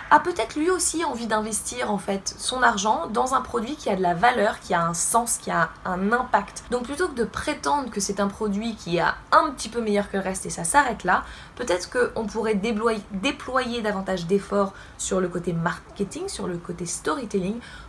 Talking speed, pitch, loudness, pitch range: 210 wpm, 215 Hz, -24 LUFS, 195-245 Hz